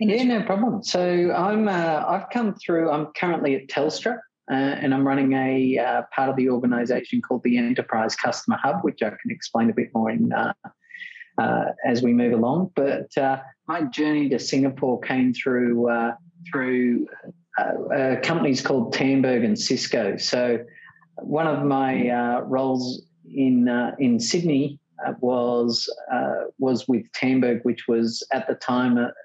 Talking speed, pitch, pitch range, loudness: 165 wpm, 135 Hz, 125-165 Hz, -23 LUFS